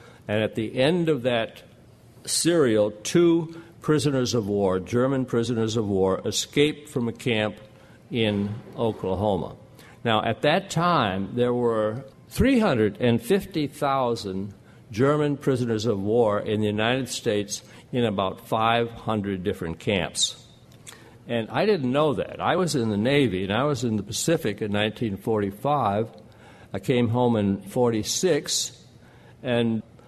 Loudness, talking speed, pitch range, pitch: -24 LUFS, 130 wpm, 105-135 Hz, 115 Hz